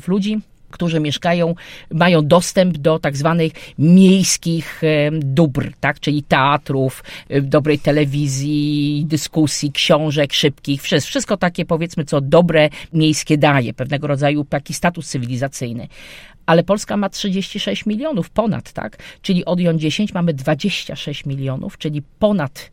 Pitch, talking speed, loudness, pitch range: 155 Hz, 125 wpm, -17 LUFS, 145-175 Hz